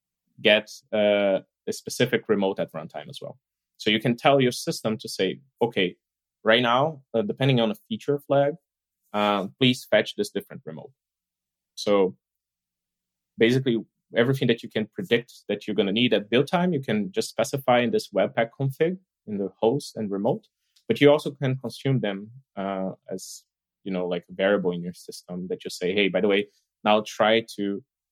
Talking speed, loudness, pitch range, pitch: 185 wpm, -24 LUFS, 95-130 Hz, 110 Hz